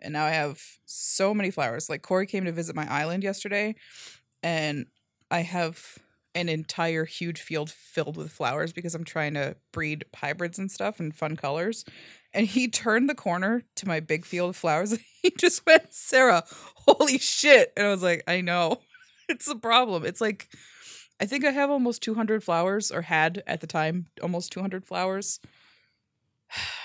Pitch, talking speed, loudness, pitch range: 175 Hz, 180 wpm, -26 LUFS, 160-220 Hz